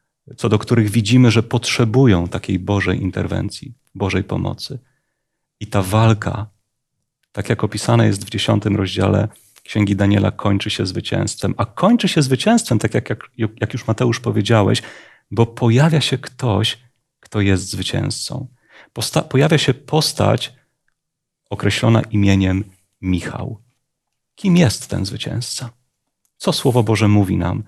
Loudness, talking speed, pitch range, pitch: -18 LUFS, 125 wpm, 105-130 Hz, 115 Hz